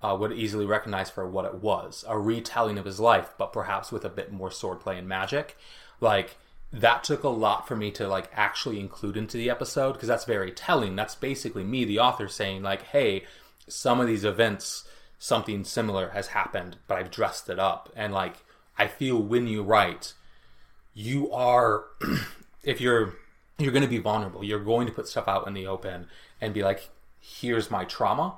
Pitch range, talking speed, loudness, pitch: 95-115 Hz, 190 wpm, -27 LUFS, 105 Hz